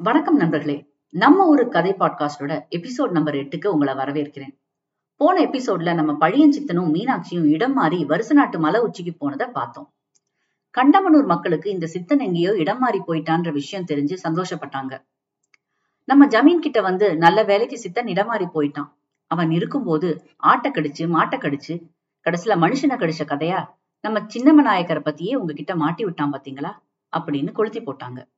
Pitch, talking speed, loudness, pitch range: 170 Hz, 145 wpm, -19 LUFS, 150-220 Hz